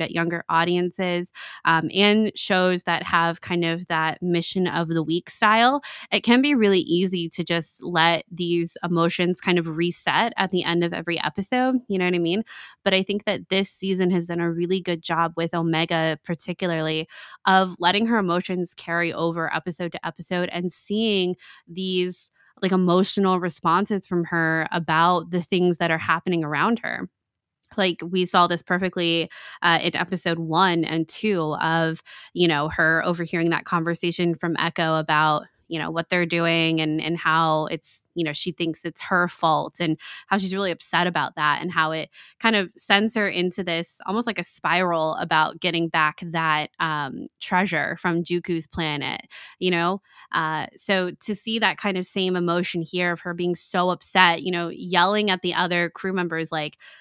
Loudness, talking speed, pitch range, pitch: -23 LUFS, 180 wpm, 165-185 Hz, 175 Hz